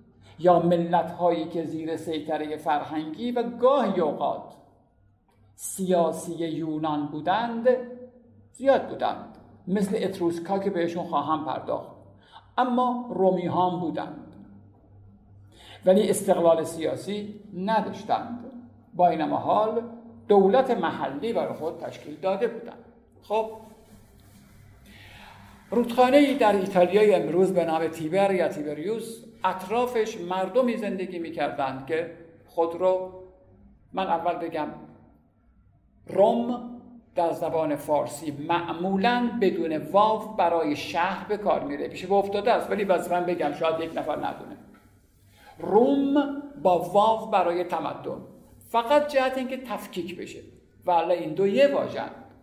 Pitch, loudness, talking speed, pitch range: 185 Hz, -25 LUFS, 115 wpm, 160-220 Hz